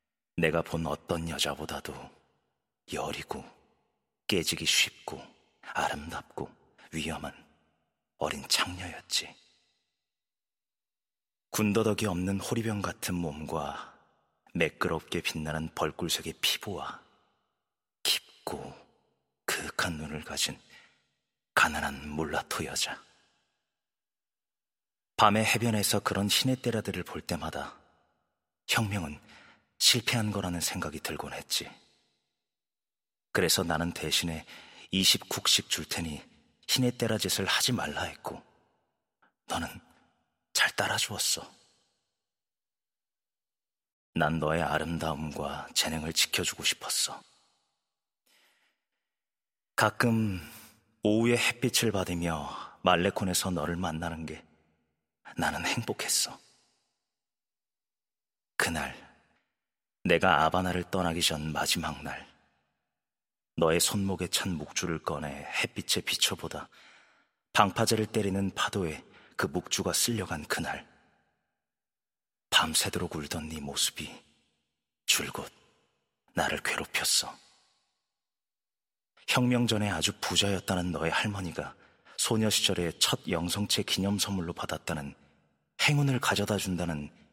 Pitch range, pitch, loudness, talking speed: 80-105 Hz, 90 Hz, -29 LUFS, 210 characters per minute